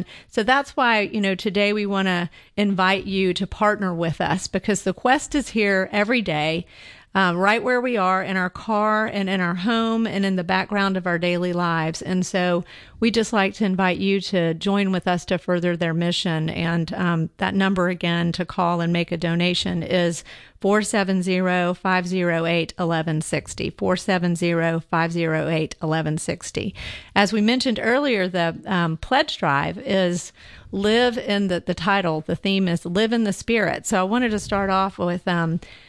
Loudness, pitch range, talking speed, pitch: -22 LUFS, 175-205 Hz, 175 wpm, 185 Hz